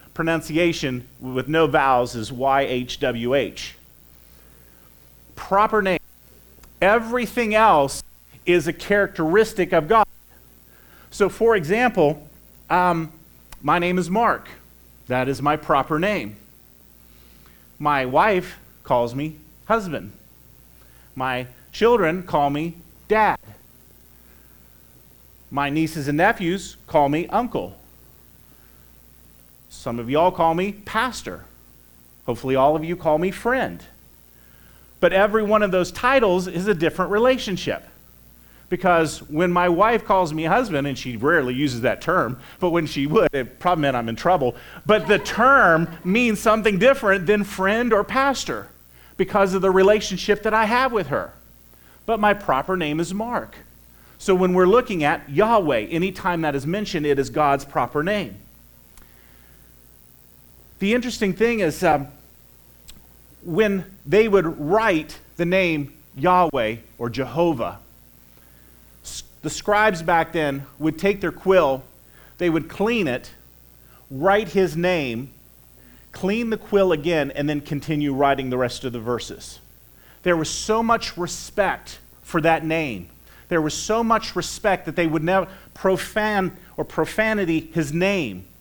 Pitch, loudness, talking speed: 160 Hz, -21 LUFS, 135 wpm